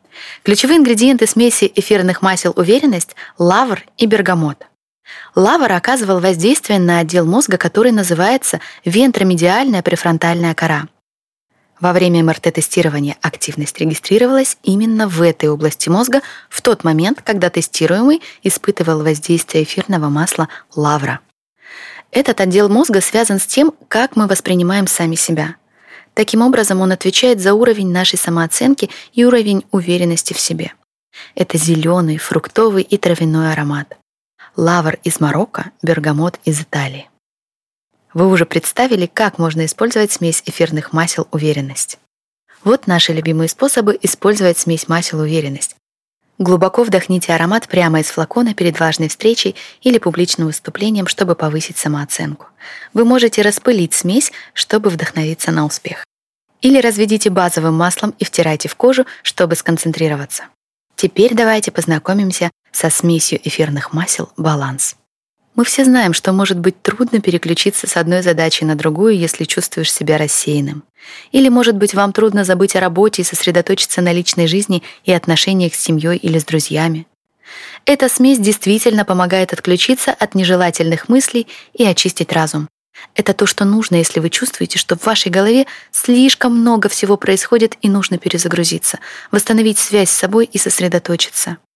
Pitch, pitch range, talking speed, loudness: 185 Hz, 165-215 Hz, 135 wpm, -13 LUFS